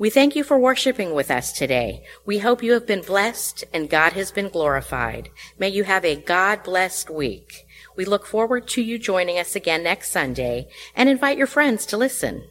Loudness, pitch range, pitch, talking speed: -21 LUFS, 180-240 Hz, 200 Hz, 195 wpm